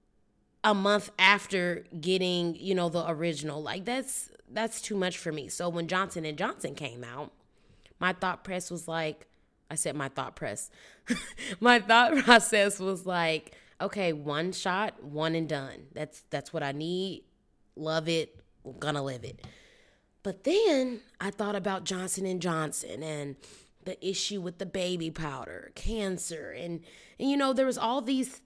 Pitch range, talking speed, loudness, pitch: 160-205 Hz, 165 wpm, -29 LUFS, 180 Hz